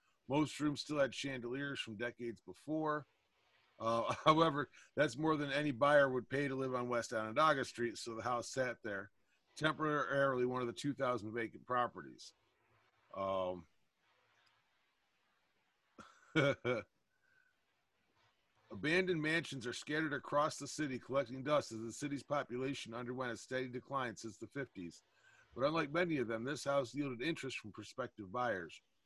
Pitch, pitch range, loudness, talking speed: 135 Hz, 120-145 Hz, -38 LUFS, 140 wpm